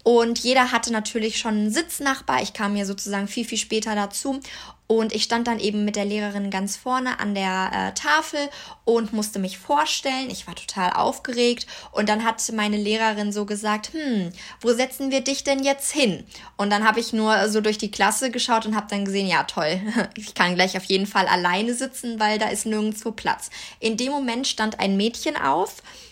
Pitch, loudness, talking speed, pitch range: 220 Hz, -23 LUFS, 200 wpm, 205-245 Hz